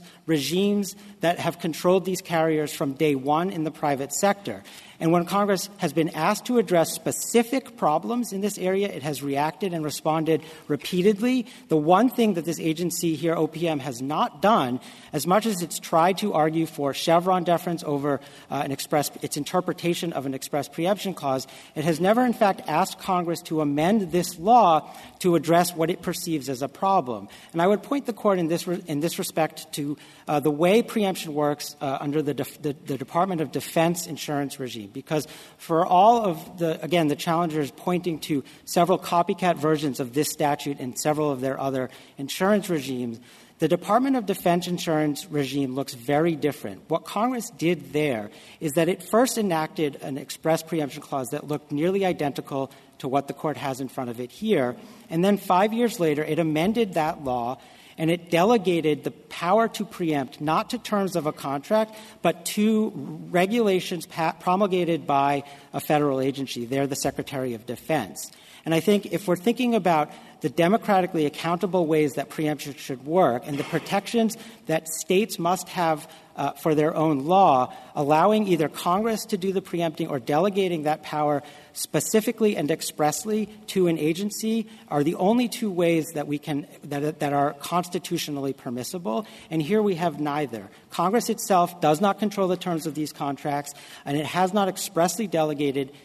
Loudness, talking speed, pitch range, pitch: -25 LUFS, 175 wpm, 145-185 Hz, 160 Hz